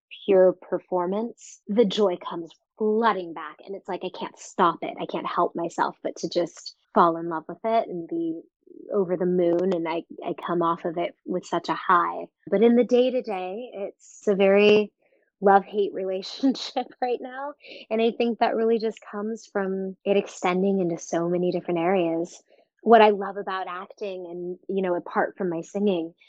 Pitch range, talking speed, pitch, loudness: 180-225 Hz, 190 wpm, 195 Hz, -25 LUFS